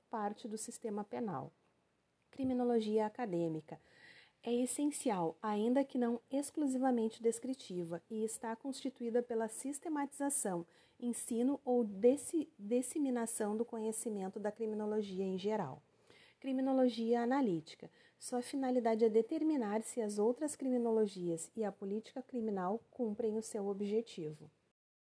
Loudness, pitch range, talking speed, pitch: -37 LUFS, 210-260 Hz, 110 wpm, 230 Hz